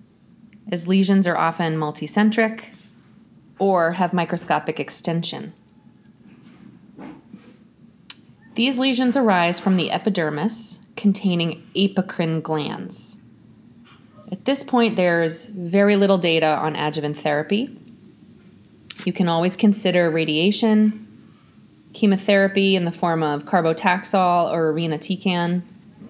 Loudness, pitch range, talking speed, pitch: -20 LUFS, 165-210 Hz, 95 wpm, 185 Hz